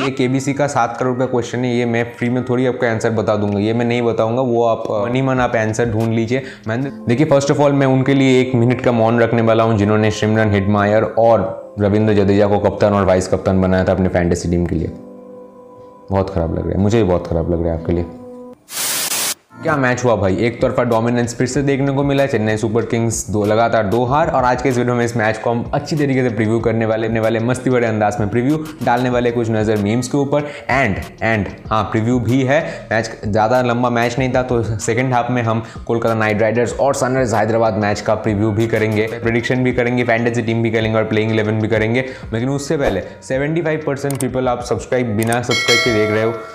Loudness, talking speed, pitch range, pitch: -16 LUFS, 225 wpm, 110-125 Hz, 115 Hz